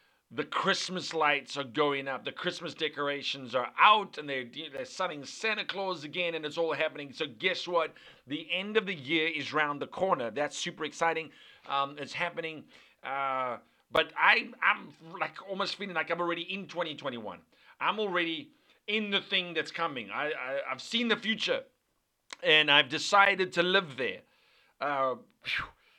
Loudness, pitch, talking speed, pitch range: -30 LUFS, 165 Hz, 165 wpm, 145-195 Hz